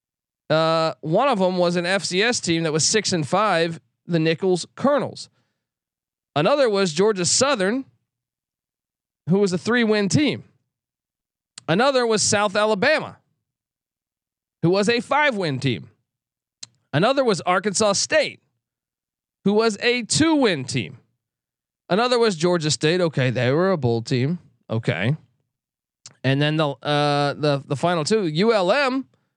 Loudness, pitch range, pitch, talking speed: -20 LUFS, 135-210 Hz, 170 Hz, 130 wpm